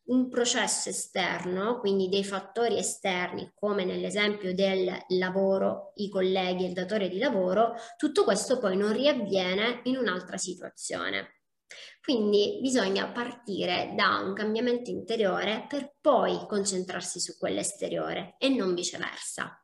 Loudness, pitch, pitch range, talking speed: -28 LUFS, 205 Hz, 190-240 Hz, 130 wpm